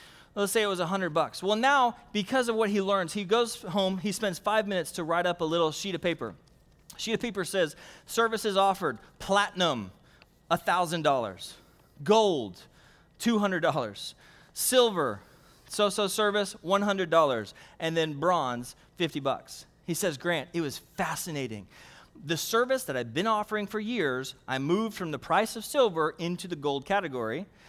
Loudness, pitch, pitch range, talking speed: -28 LUFS, 185 Hz, 160-210 Hz, 155 wpm